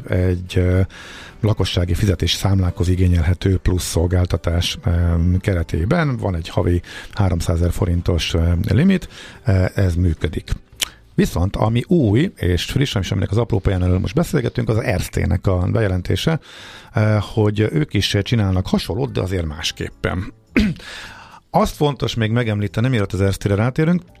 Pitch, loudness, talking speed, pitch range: 95 Hz, -19 LUFS, 125 wpm, 90-110 Hz